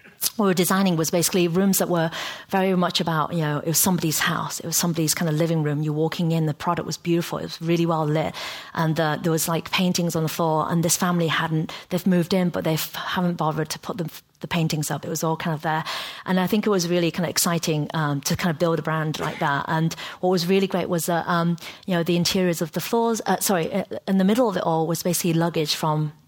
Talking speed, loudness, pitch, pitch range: 265 wpm, -23 LUFS, 170 Hz, 160-180 Hz